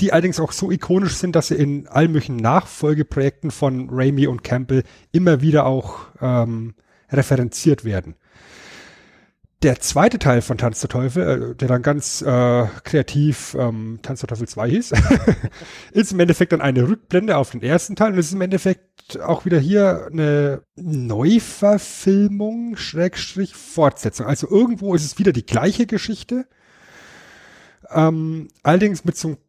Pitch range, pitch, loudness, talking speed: 130-185 Hz, 150 Hz, -19 LUFS, 150 wpm